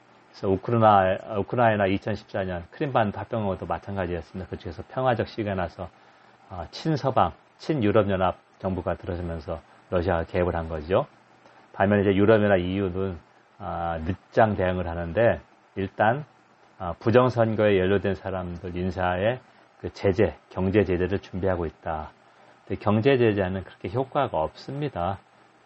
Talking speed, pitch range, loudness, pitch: 310 characters per minute, 90-110 Hz, -25 LUFS, 95 Hz